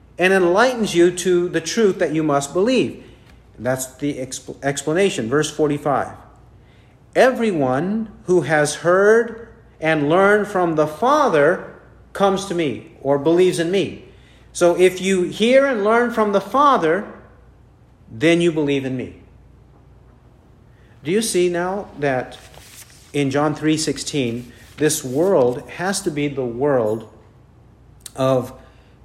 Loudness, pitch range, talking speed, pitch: -18 LUFS, 125-185 Hz, 130 wpm, 150 Hz